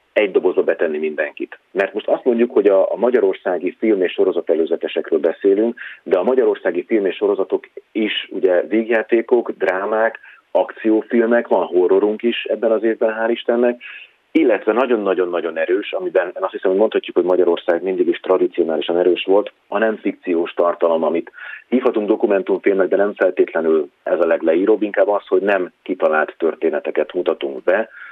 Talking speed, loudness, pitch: 155 wpm, -18 LUFS, 385 Hz